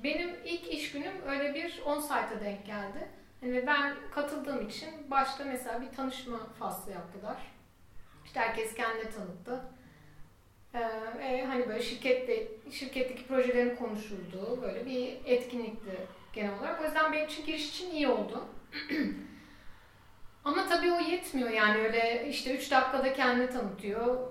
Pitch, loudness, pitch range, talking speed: 255 Hz, -33 LUFS, 225-285 Hz, 140 wpm